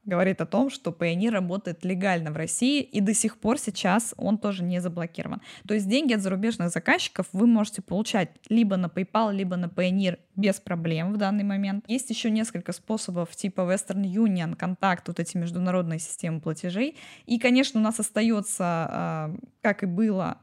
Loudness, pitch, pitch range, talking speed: -26 LUFS, 195 Hz, 180-220 Hz, 175 wpm